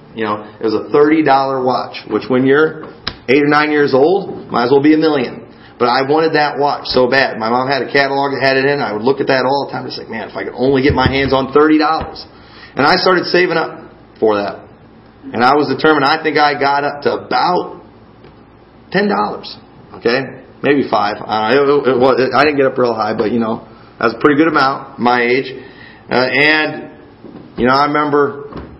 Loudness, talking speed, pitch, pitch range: -14 LUFS, 225 wpm, 140 Hz, 125-150 Hz